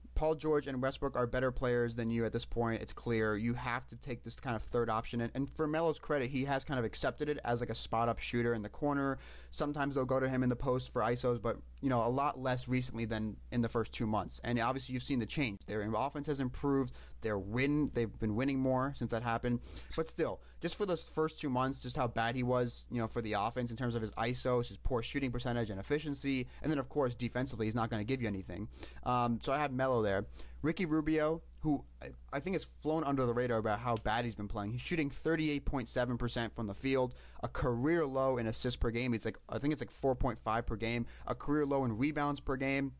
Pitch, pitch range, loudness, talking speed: 125 Hz, 115-140 Hz, -36 LUFS, 240 wpm